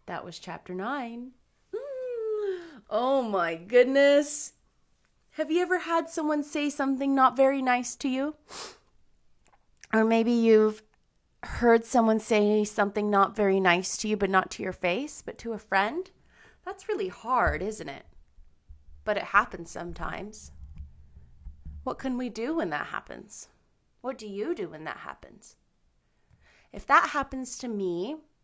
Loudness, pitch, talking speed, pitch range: -27 LUFS, 225 Hz, 145 wpm, 190-280 Hz